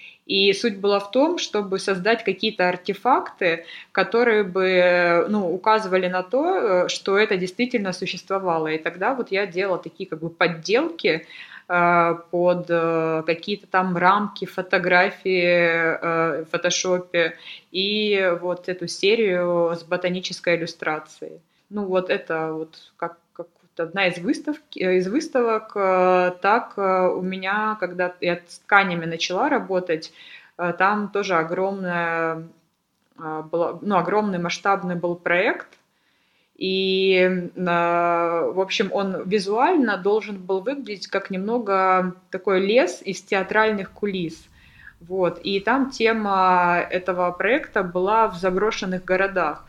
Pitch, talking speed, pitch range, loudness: 185 Hz, 115 wpm, 175-200 Hz, -22 LUFS